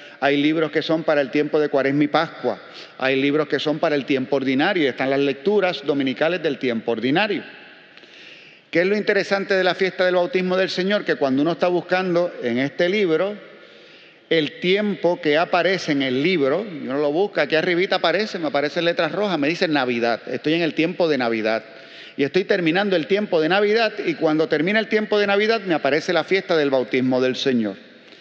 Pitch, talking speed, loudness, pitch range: 160 Hz, 200 wpm, -20 LUFS, 140-185 Hz